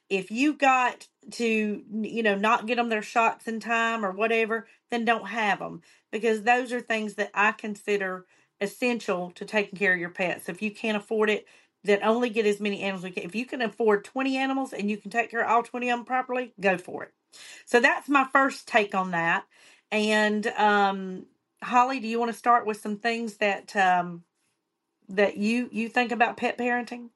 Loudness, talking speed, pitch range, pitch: -26 LUFS, 205 wpm, 205-240 Hz, 220 Hz